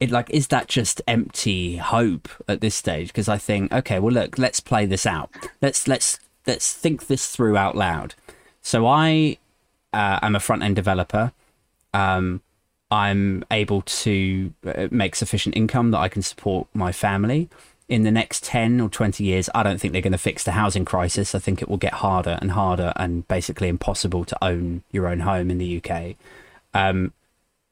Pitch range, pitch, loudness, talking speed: 95-115 Hz, 100 Hz, -22 LUFS, 180 wpm